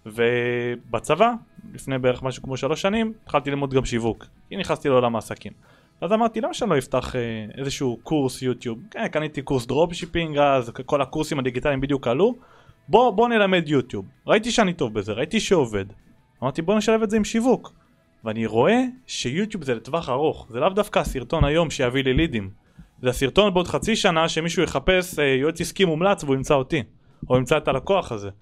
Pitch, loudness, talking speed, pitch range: 145 Hz, -22 LUFS, 175 wpm, 125-185 Hz